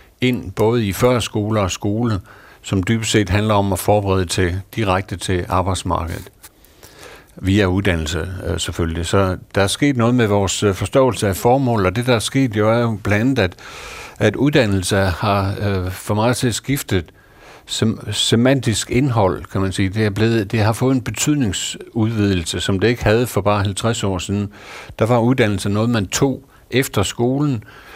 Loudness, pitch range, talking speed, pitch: -18 LUFS, 95-115 Hz, 170 wpm, 105 Hz